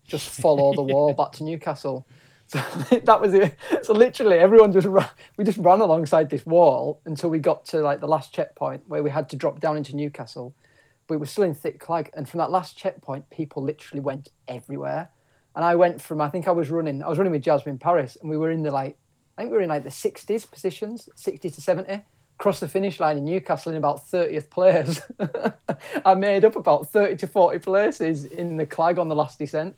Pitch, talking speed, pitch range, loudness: 160 Hz, 225 wpm, 145-185 Hz, -22 LUFS